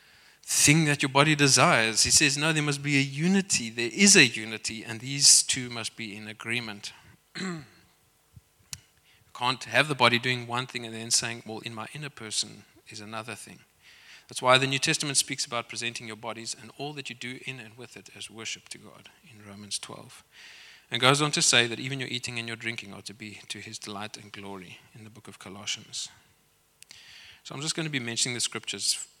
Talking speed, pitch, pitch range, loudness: 215 wpm, 120 Hz, 110-140 Hz, -24 LUFS